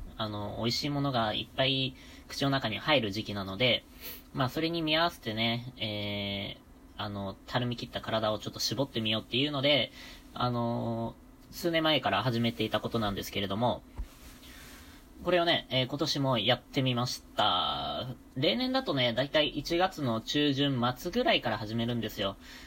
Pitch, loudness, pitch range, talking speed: 120 Hz, -30 LUFS, 110-140 Hz, 335 characters per minute